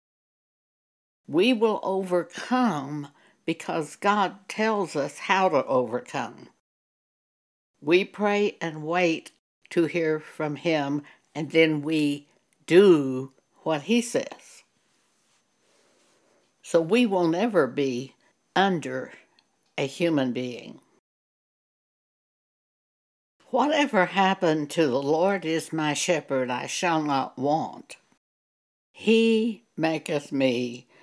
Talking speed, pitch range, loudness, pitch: 95 wpm, 145-195 Hz, -25 LUFS, 160 Hz